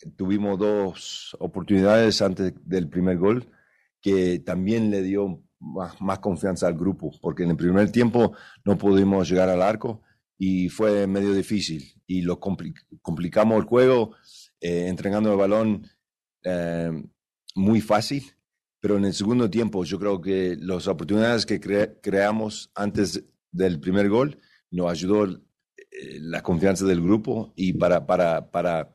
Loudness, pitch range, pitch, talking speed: -23 LUFS, 90-105 Hz, 100 Hz, 150 wpm